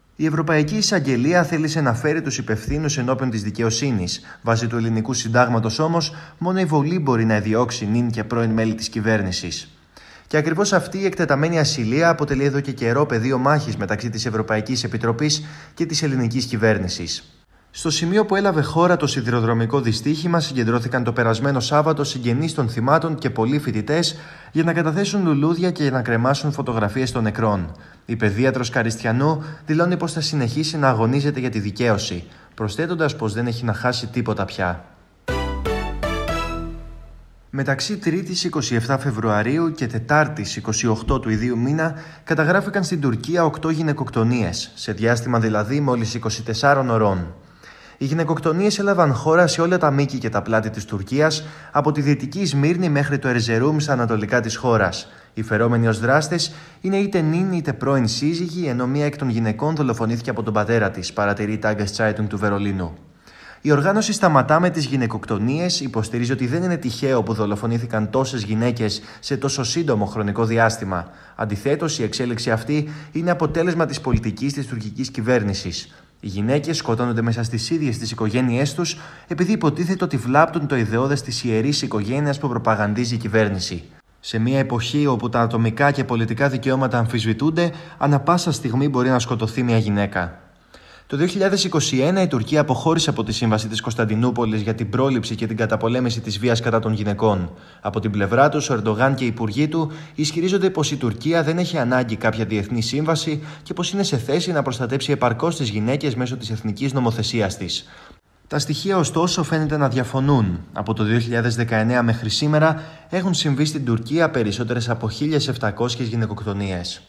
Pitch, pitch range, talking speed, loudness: 125 Hz, 110-155 Hz, 160 wpm, -21 LUFS